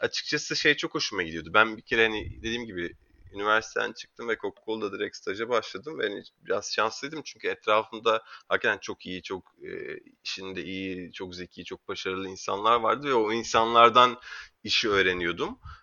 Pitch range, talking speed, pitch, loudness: 95-125 Hz, 155 wpm, 110 Hz, -27 LUFS